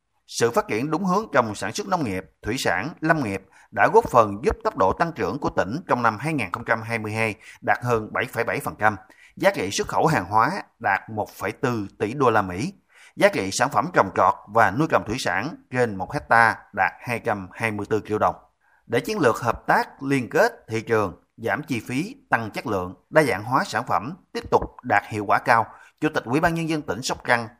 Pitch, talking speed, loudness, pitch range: 115 Hz, 205 wpm, -23 LUFS, 105-150 Hz